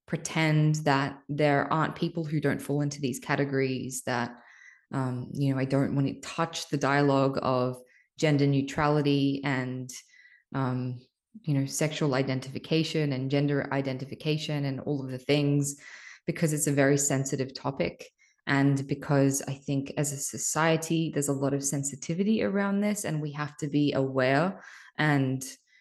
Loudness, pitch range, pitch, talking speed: -28 LUFS, 135-155 Hz, 140 Hz, 155 wpm